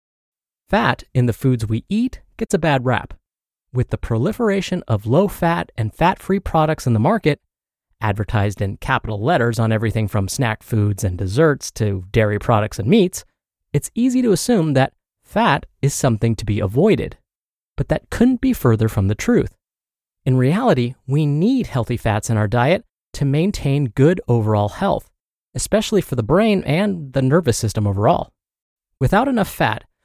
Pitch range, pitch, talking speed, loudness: 110-170 Hz, 125 Hz, 170 wpm, -19 LUFS